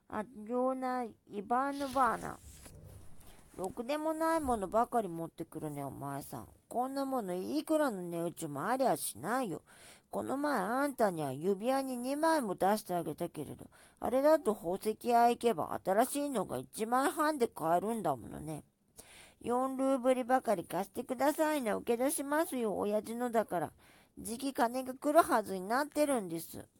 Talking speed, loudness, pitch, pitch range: 325 characters per minute, -34 LUFS, 235 Hz, 175-265 Hz